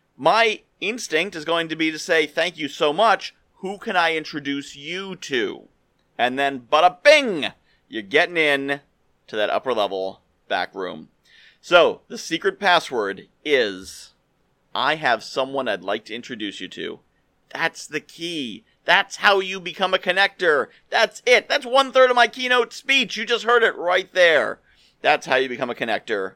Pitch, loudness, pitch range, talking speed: 170 Hz, -20 LUFS, 145-215 Hz, 175 wpm